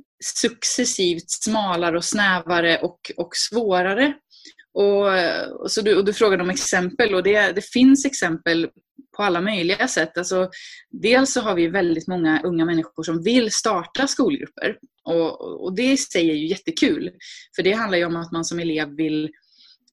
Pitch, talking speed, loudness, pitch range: 195 Hz, 160 wpm, -20 LUFS, 170-250 Hz